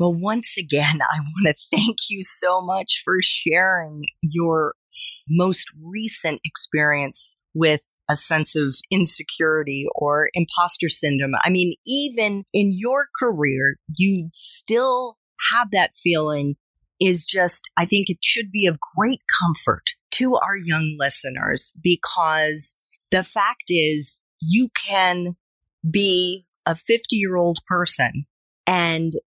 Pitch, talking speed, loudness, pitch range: 175 Hz, 125 wpm, -19 LUFS, 155-195 Hz